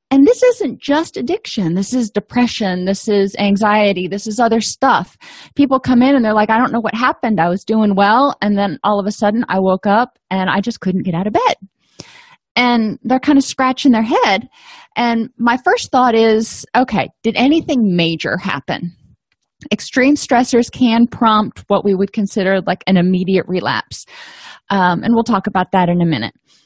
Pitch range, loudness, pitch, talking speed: 195-255 Hz, -15 LUFS, 220 Hz, 190 wpm